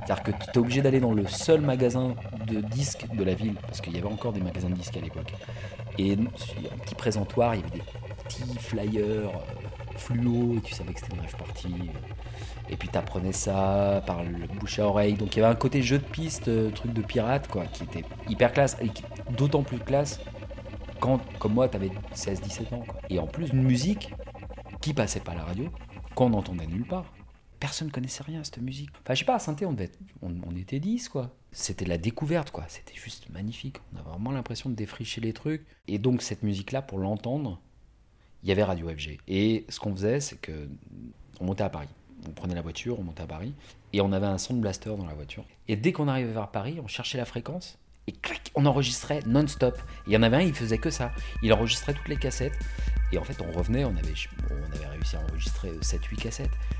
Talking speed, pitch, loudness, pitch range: 235 wpm, 110 Hz, -29 LUFS, 95-125 Hz